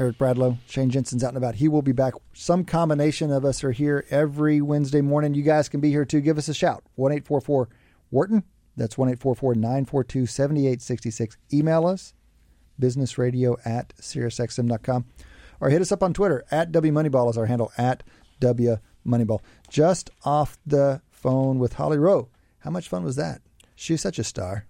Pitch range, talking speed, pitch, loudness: 120-150 Hz, 175 wpm, 135 Hz, -23 LUFS